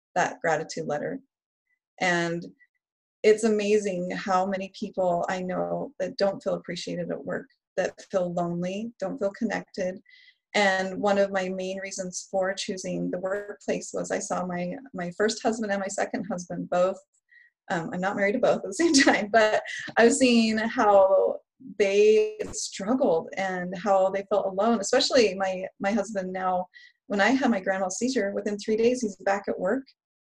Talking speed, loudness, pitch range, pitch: 165 wpm, -26 LUFS, 190-235 Hz, 200 Hz